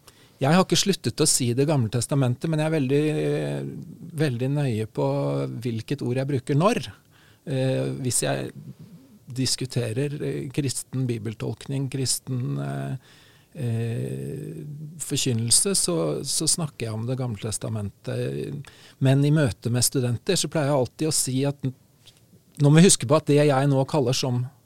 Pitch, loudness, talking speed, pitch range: 135 Hz, -24 LUFS, 150 wpm, 120-150 Hz